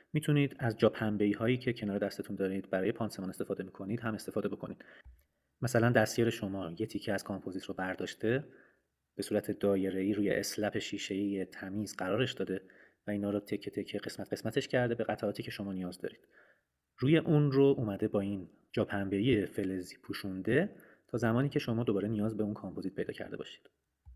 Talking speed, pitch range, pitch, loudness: 170 wpm, 95-115 Hz, 105 Hz, -34 LUFS